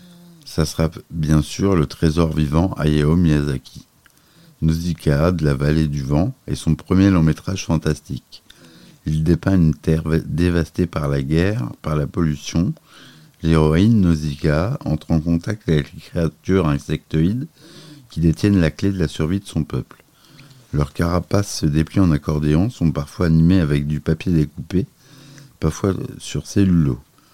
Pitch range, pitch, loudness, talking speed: 75-95 Hz, 80 Hz, -19 LUFS, 145 wpm